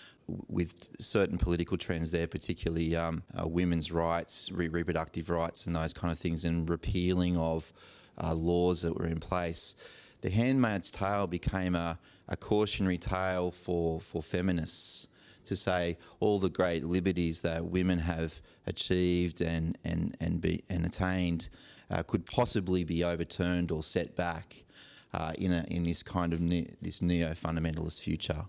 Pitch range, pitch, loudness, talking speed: 85-90 Hz, 85 Hz, -31 LUFS, 155 wpm